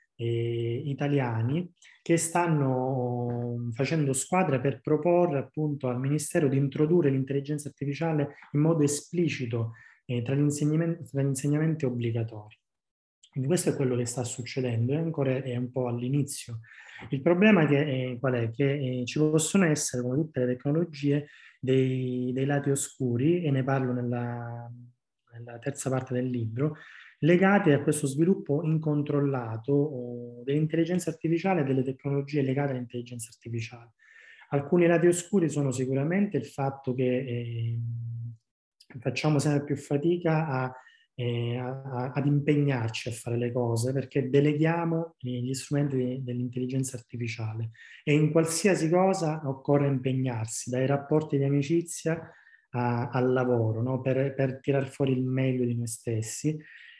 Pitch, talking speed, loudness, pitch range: 135 Hz, 135 wpm, -28 LUFS, 125-150 Hz